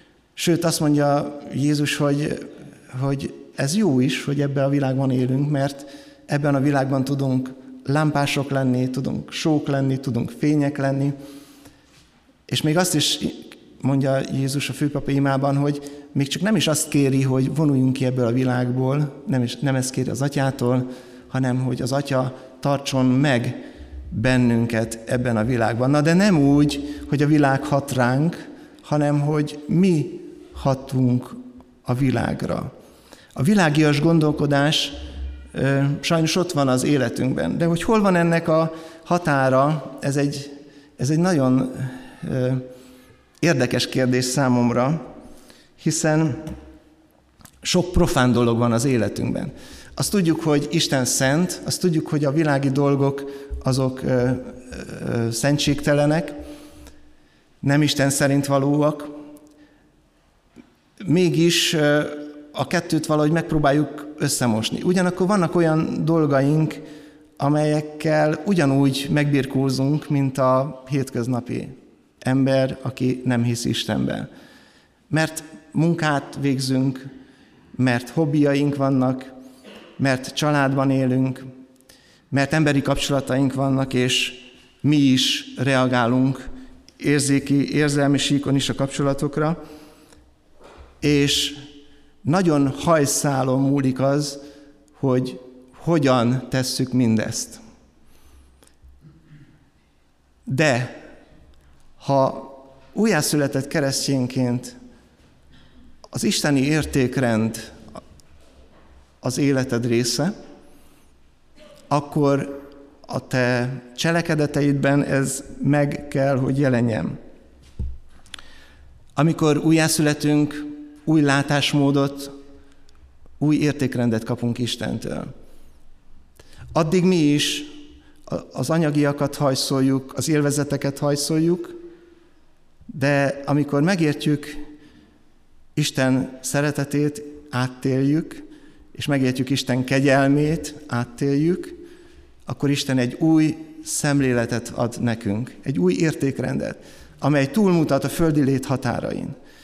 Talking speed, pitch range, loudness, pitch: 100 wpm, 130-150 Hz, -21 LUFS, 140 Hz